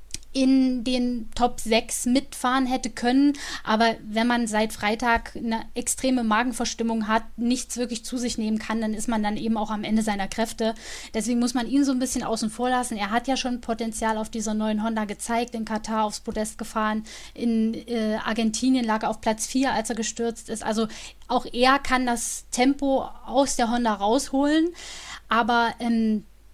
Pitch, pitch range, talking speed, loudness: 230 Hz, 220-250 Hz, 185 wpm, -25 LUFS